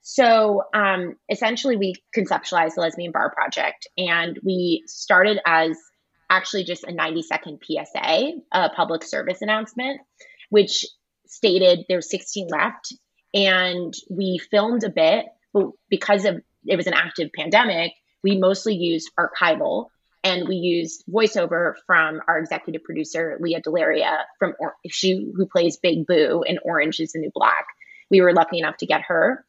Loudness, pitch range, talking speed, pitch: -21 LUFS, 165-205 Hz, 150 wpm, 185 Hz